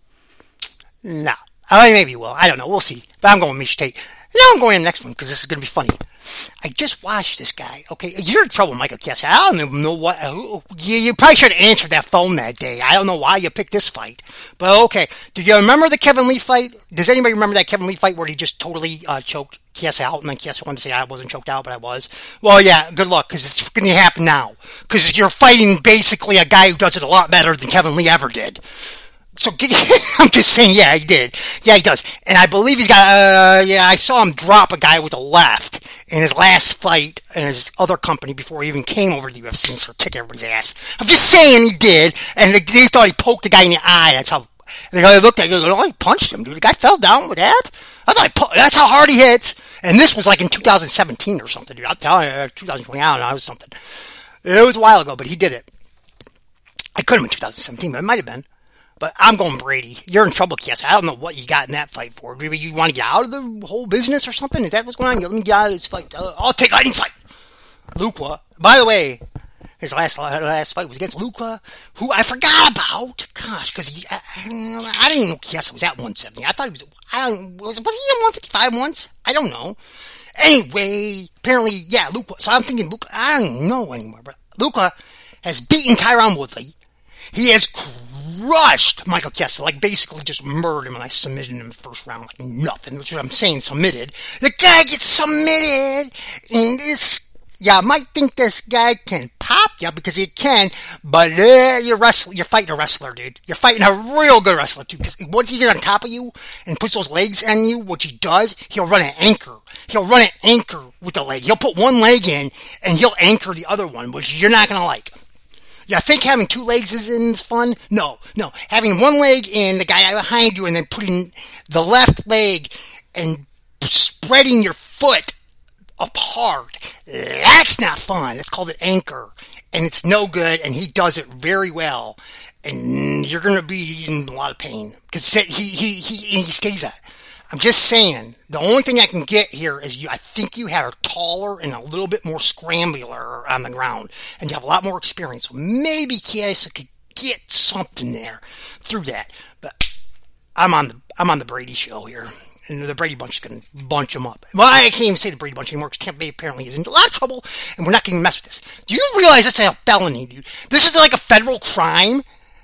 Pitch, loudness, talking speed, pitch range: 195 Hz, -12 LUFS, 235 wpm, 160-235 Hz